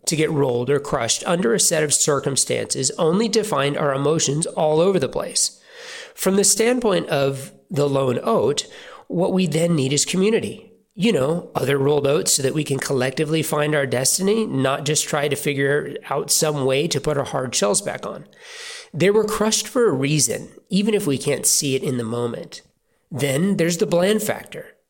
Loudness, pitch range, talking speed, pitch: -20 LUFS, 140-210 Hz, 195 wpm, 155 Hz